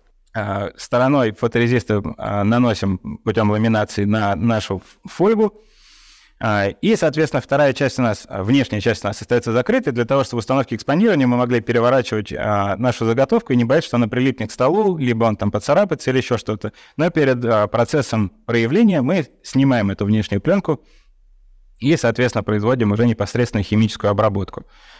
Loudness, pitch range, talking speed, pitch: -18 LUFS, 105-135 Hz, 155 wpm, 120 Hz